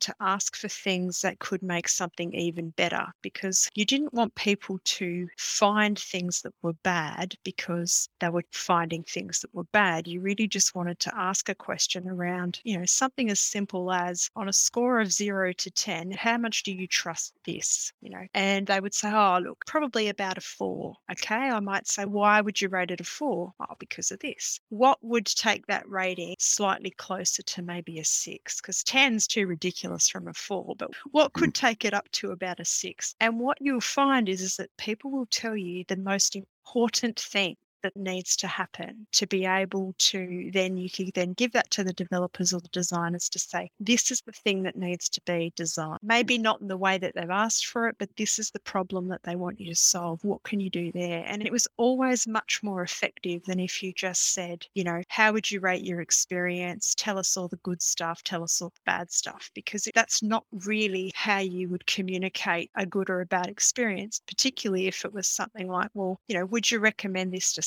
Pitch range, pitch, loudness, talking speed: 180-215 Hz, 190 Hz, -27 LUFS, 215 wpm